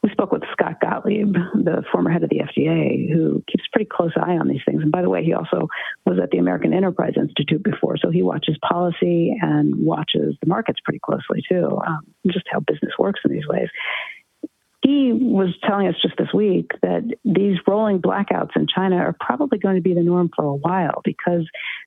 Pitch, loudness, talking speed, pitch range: 185 Hz, -20 LUFS, 205 wpm, 170-210 Hz